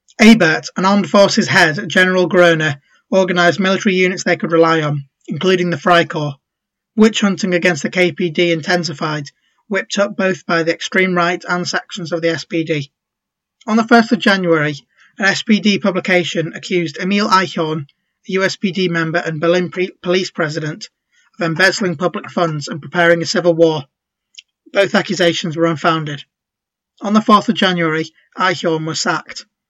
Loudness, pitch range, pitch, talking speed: -15 LUFS, 165-190 Hz, 180 Hz, 155 wpm